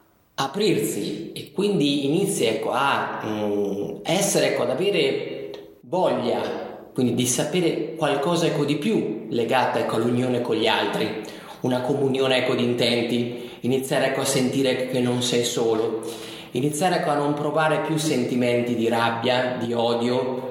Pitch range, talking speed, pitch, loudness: 120-150 Hz, 145 wpm, 130 Hz, -23 LUFS